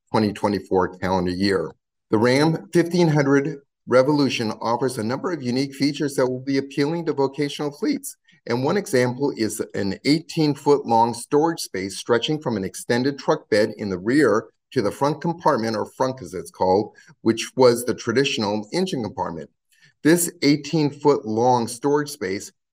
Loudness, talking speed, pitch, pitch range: -22 LUFS, 160 wpm, 135 Hz, 110-150 Hz